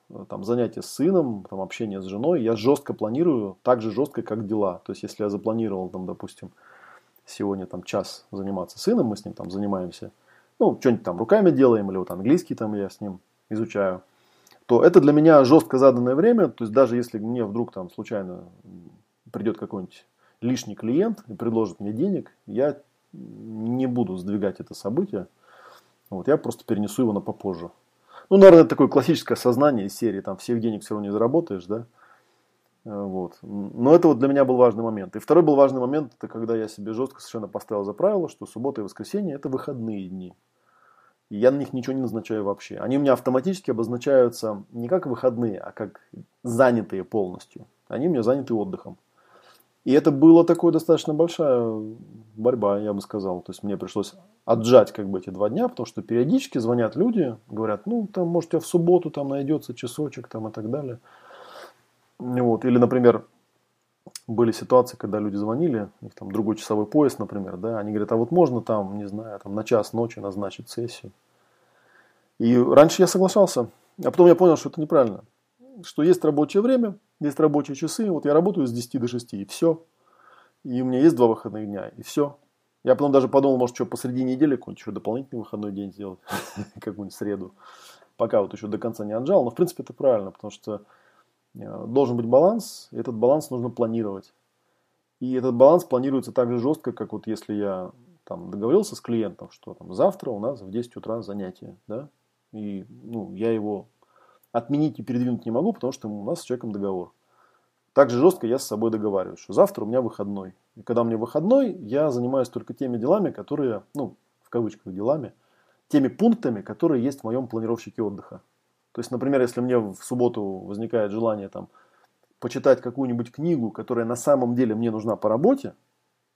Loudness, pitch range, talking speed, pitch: -23 LUFS, 105-135 Hz, 185 wpm, 120 Hz